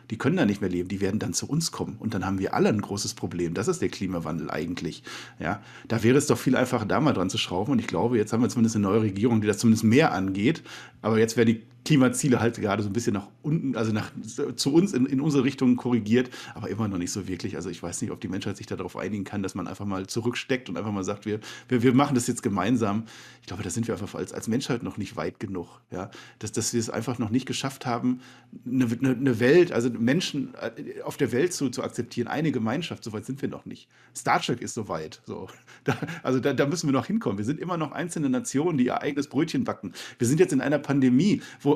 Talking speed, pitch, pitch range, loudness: 260 wpm, 120 Hz, 105-130 Hz, -26 LUFS